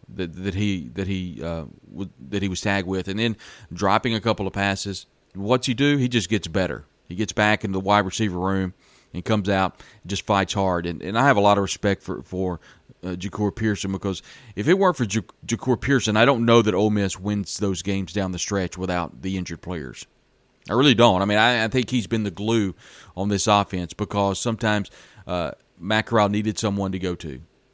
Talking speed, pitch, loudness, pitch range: 220 wpm, 100 Hz, -23 LUFS, 95-110 Hz